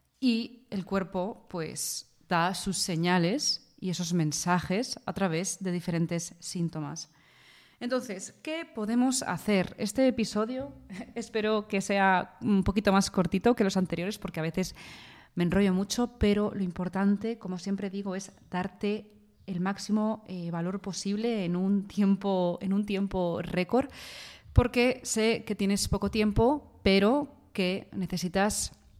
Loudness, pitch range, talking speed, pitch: -29 LUFS, 180-215 Hz, 135 wpm, 195 Hz